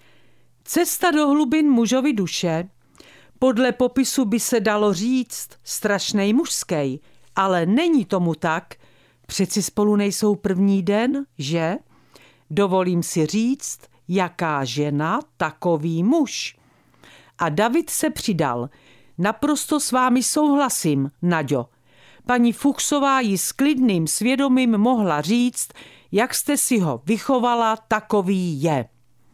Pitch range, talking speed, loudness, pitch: 170-255 Hz, 110 wpm, -21 LUFS, 210 Hz